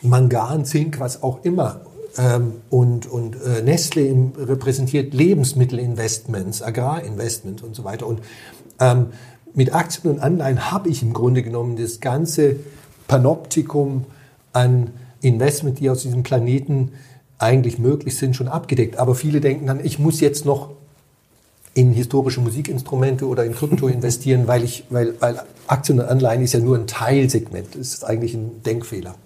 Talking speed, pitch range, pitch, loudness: 150 wpm, 120-140 Hz, 130 Hz, -19 LUFS